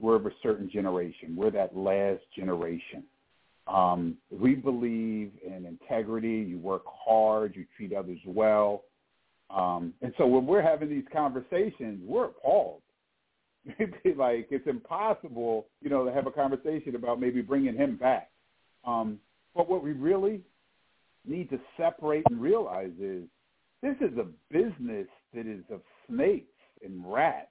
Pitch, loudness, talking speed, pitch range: 120 Hz, -29 LUFS, 145 wpm, 100-155 Hz